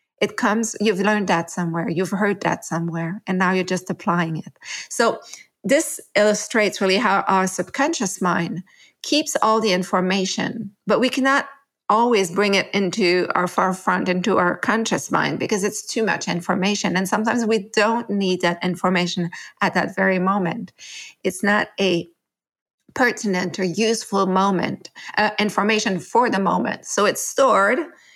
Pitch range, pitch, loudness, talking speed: 185-215 Hz, 195 Hz, -20 LUFS, 155 wpm